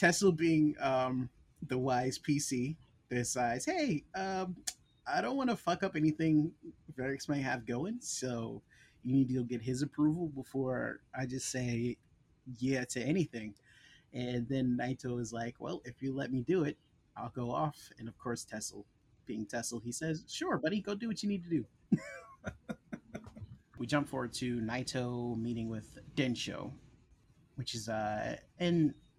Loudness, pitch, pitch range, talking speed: -36 LUFS, 130 Hz, 120-155 Hz, 160 wpm